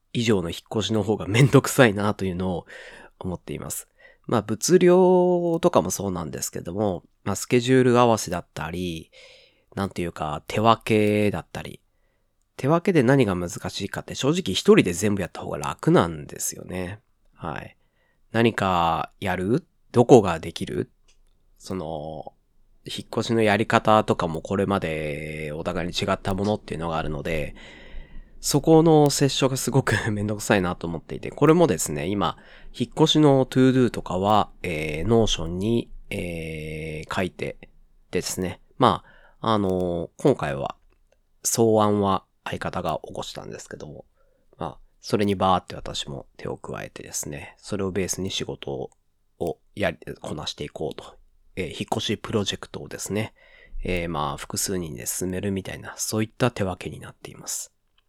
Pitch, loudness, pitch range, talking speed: 100 Hz, -23 LUFS, 90-115 Hz, 325 characters per minute